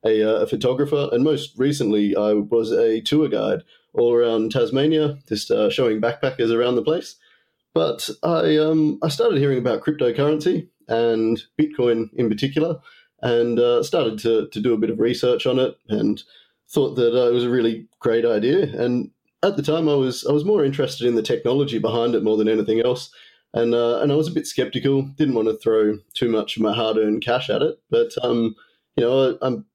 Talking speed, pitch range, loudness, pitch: 205 wpm, 115-150 Hz, -20 LUFS, 120 Hz